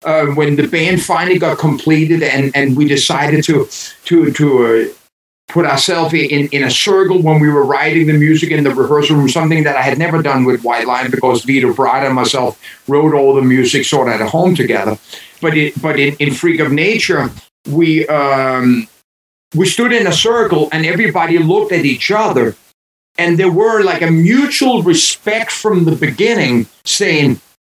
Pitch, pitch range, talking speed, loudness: 155 Hz, 140-170 Hz, 185 wpm, -12 LUFS